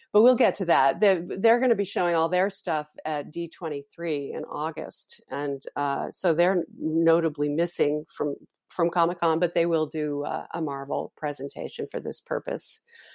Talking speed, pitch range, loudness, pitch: 175 wpm, 150-180 Hz, -26 LUFS, 165 Hz